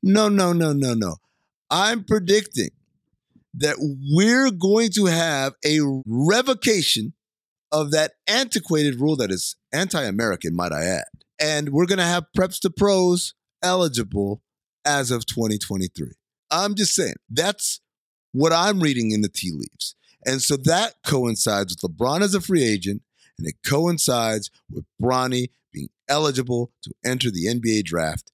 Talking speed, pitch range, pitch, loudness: 150 wpm, 120-180 Hz, 150 Hz, -21 LUFS